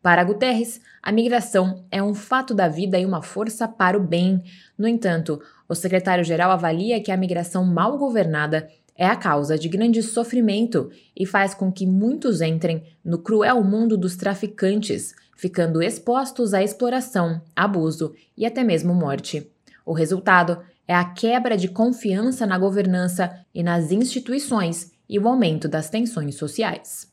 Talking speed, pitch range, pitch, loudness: 155 wpm, 175-225 Hz, 190 Hz, -21 LUFS